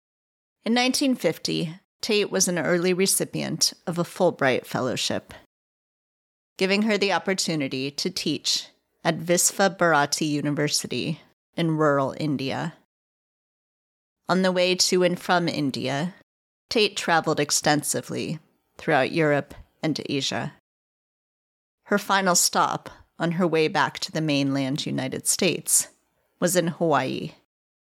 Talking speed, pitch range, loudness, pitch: 115 wpm, 145-185 Hz, -23 LUFS, 170 Hz